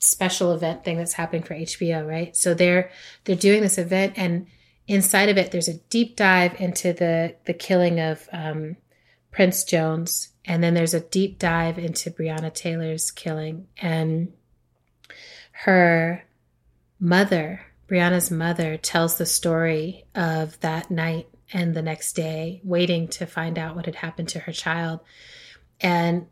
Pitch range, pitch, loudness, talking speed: 165-180 Hz, 170 Hz, -23 LUFS, 150 wpm